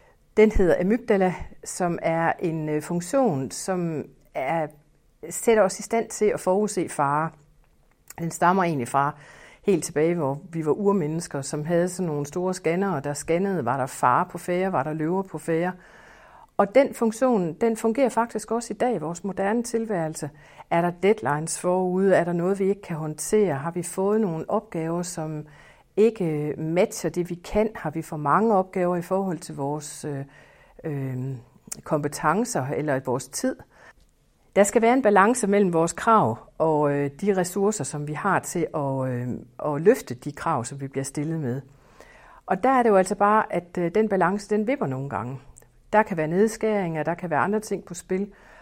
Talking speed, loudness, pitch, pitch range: 185 wpm, -24 LUFS, 175 Hz, 150-205 Hz